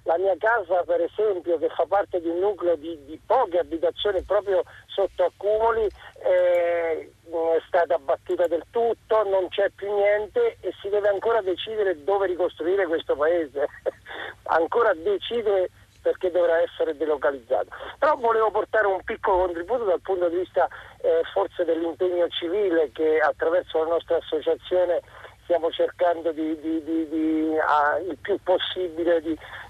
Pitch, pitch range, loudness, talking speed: 180 Hz, 165-210 Hz, -24 LUFS, 150 wpm